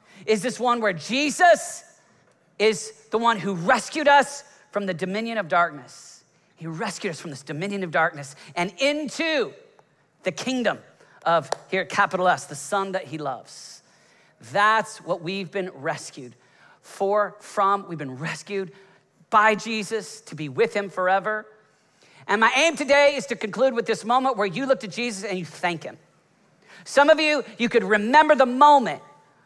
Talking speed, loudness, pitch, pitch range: 165 wpm, -22 LUFS, 210 Hz, 180-245 Hz